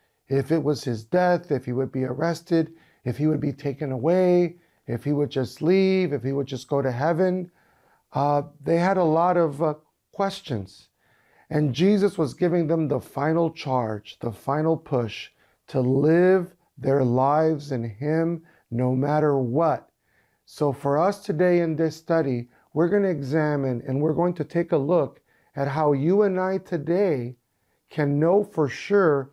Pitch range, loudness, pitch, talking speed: 135-170 Hz, -24 LUFS, 155 Hz, 170 wpm